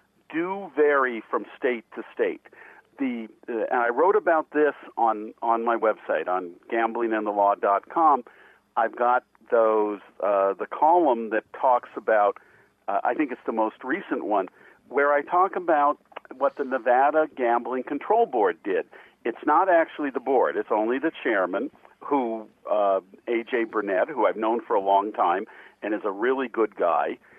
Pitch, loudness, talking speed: 130 Hz, -24 LUFS, 160 wpm